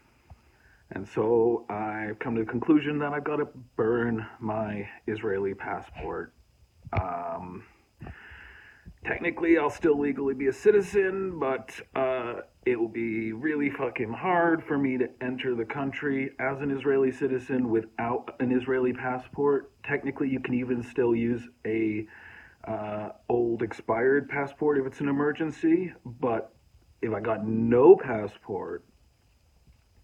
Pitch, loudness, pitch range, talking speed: 130 Hz, -28 LUFS, 115-145 Hz, 130 wpm